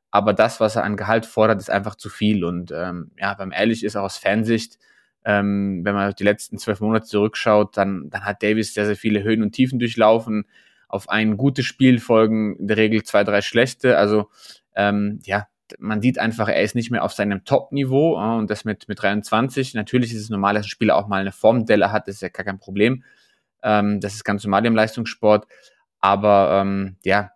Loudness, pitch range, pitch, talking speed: -20 LUFS, 100-110 Hz, 105 Hz, 215 wpm